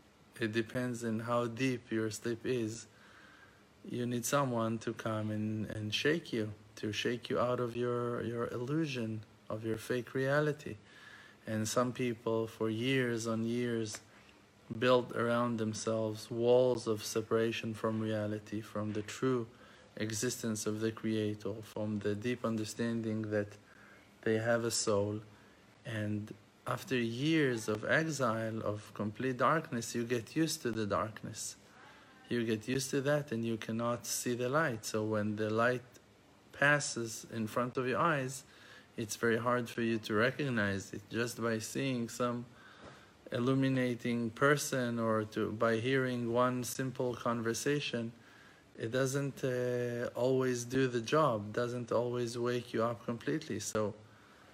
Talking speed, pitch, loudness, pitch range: 145 wpm, 115 Hz, -35 LUFS, 110-125 Hz